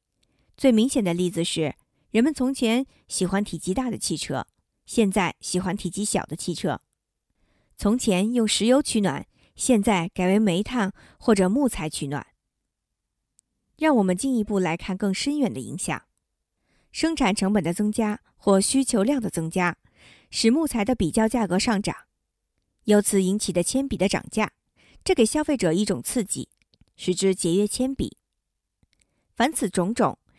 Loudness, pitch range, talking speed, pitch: -24 LUFS, 180-240 Hz, 225 characters per minute, 205 Hz